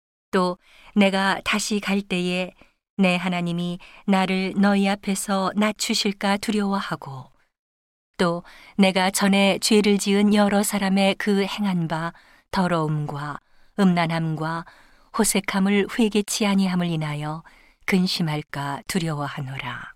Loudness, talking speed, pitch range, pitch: -22 LUFS, 240 characters per minute, 165-200 Hz, 190 Hz